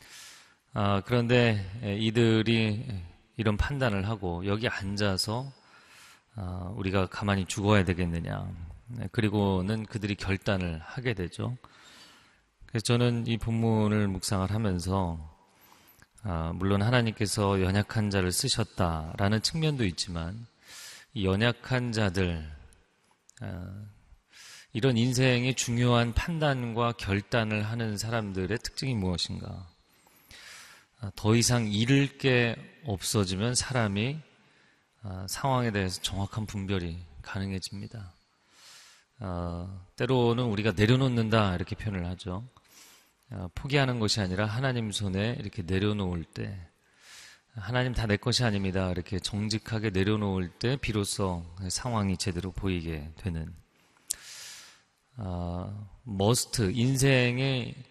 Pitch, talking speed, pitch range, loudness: 105 Hz, 250 characters per minute, 95-115 Hz, -29 LUFS